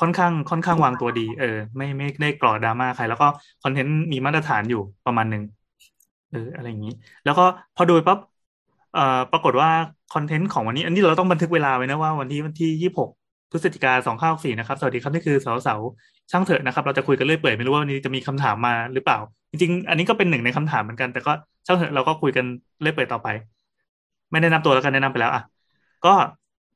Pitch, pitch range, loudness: 140 Hz, 125-165 Hz, -21 LUFS